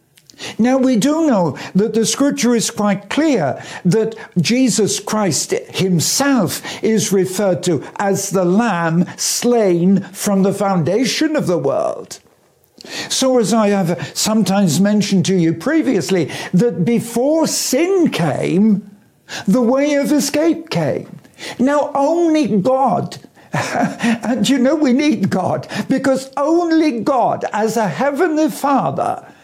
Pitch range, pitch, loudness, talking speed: 190-275 Hz, 220 Hz, -16 LUFS, 125 wpm